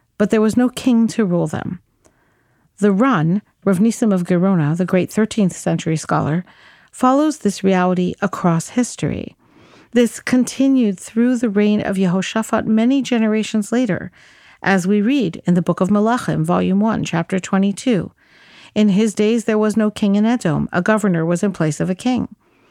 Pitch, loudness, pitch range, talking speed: 210 Hz, -17 LUFS, 185-230 Hz, 165 wpm